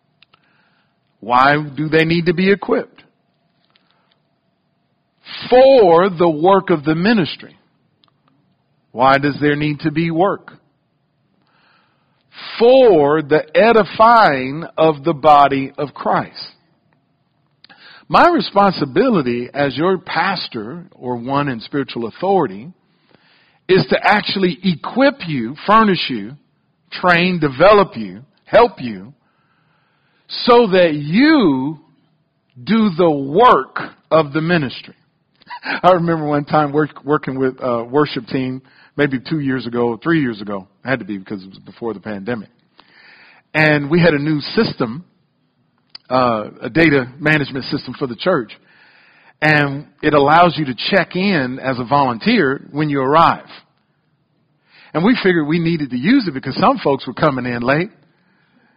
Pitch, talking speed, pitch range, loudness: 155 Hz, 130 wpm, 135-180 Hz, -15 LUFS